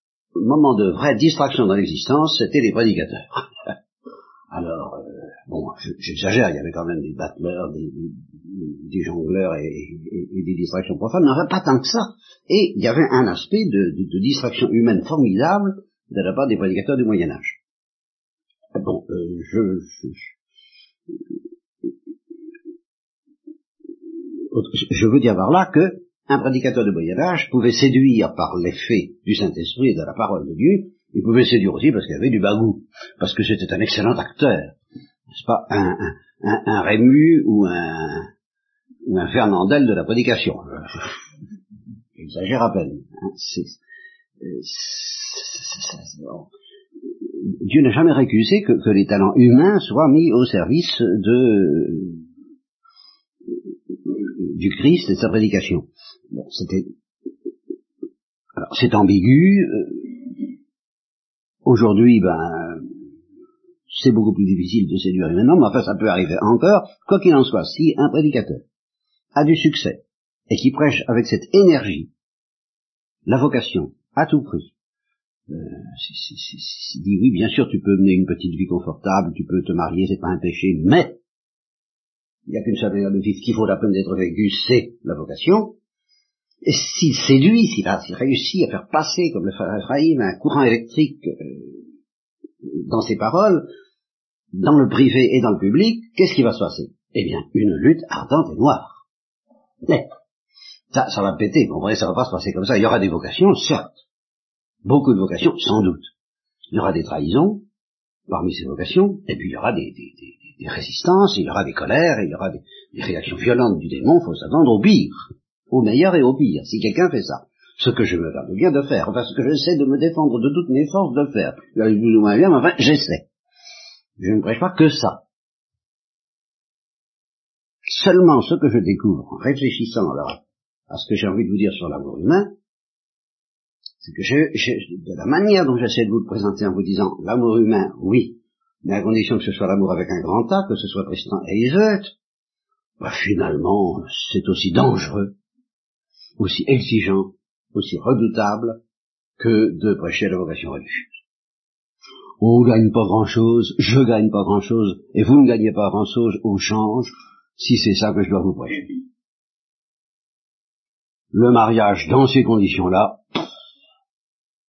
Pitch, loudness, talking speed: 135 Hz, -18 LUFS, 170 wpm